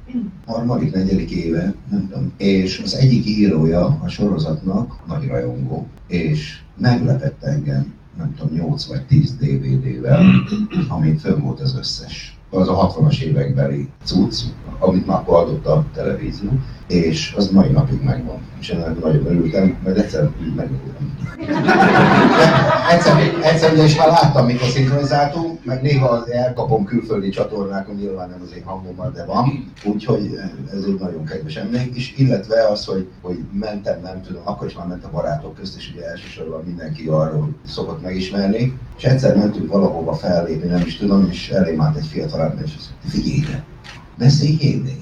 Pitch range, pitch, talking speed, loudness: 90-145 Hz, 115 Hz, 155 wpm, -18 LUFS